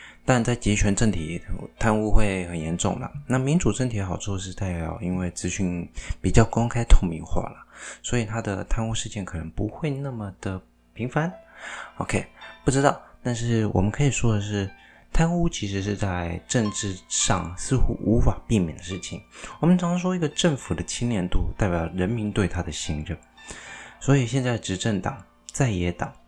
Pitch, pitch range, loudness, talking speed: 105 Hz, 90-120 Hz, -25 LUFS, 265 characters per minute